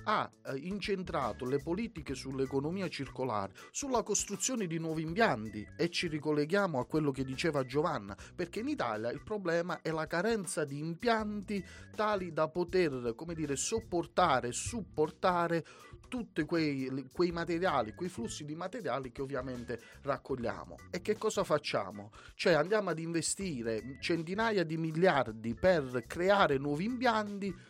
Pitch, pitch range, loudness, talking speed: 165 Hz, 135-195 Hz, -34 LUFS, 135 wpm